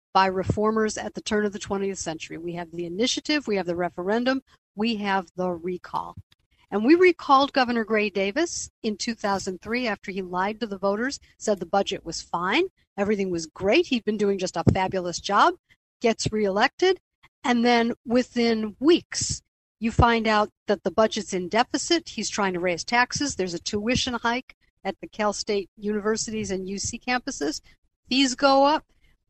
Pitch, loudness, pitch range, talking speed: 210 Hz, -24 LUFS, 190-240 Hz, 170 wpm